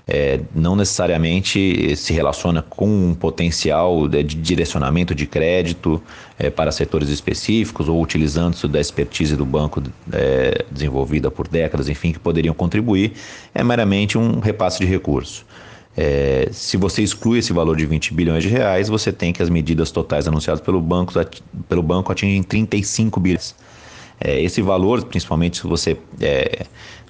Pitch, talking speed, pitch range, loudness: 85 Hz, 150 wpm, 80-100 Hz, -19 LUFS